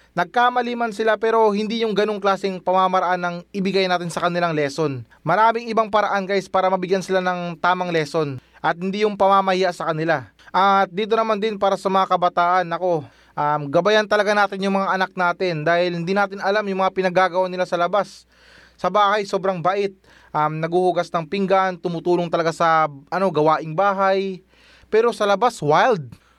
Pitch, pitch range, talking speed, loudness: 185 Hz, 175-200 Hz, 175 wpm, -20 LUFS